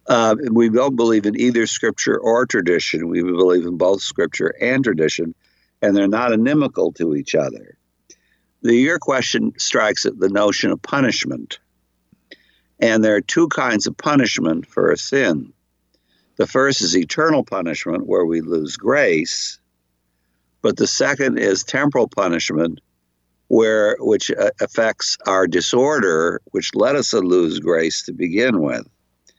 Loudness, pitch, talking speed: -18 LUFS, 85 Hz, 145 wpm